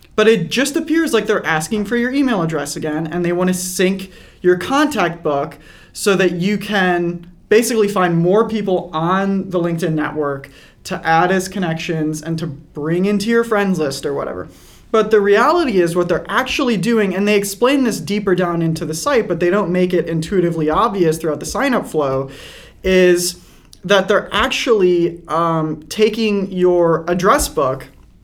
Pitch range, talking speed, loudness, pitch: 165-210 Hz, 175 wpm, -16 LUFS, 180 Hz